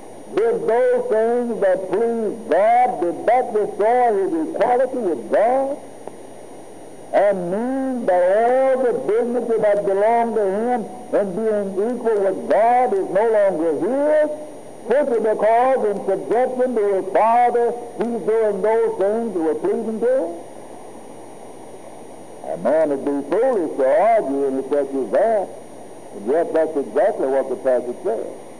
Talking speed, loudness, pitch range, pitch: 140 wpm, -19 LUFS, 195-265 Hz, 230 Hz